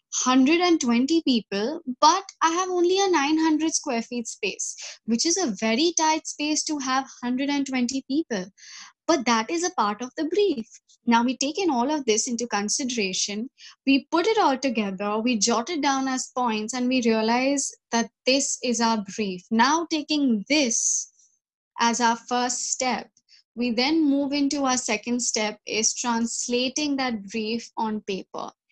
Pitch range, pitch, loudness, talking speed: 230-305 Hz, 255 Hz, -24 LUFS, 165 wpm